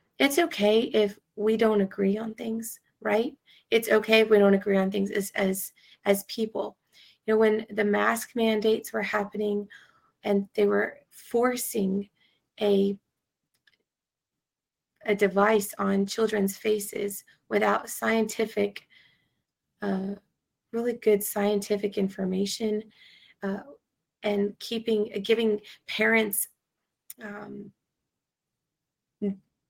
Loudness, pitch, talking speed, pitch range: -26 LUFS, 210 Hz, 105 wpm, 200-220 Hz